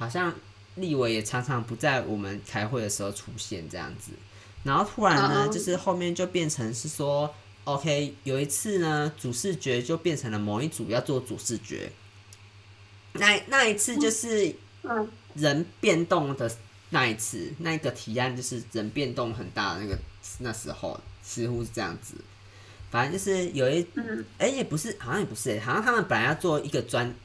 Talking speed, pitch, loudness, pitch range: 270 characters per minute, 125 Hz, -28 LUFS, 105-155 Hz